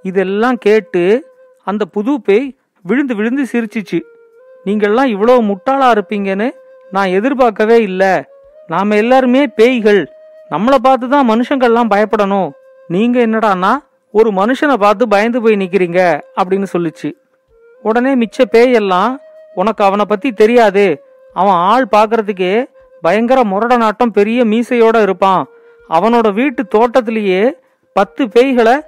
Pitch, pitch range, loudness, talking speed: 230 Hz, 200-260 Hz, -12 LUFS, 110 wpm